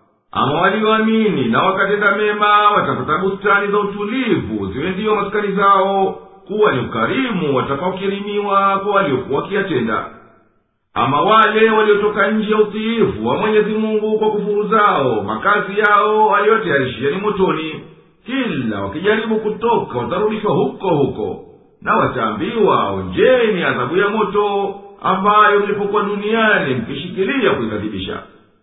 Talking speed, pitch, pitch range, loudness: 110 wpm, 205 Hz, 195-215 Hz, -16 LUFS